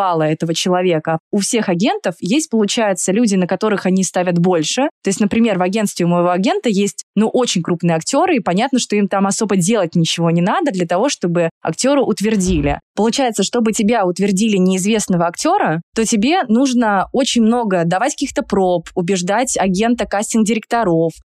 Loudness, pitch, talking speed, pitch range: -16 LUFS, 200 Hz, 165 wpm, 180-230 Hz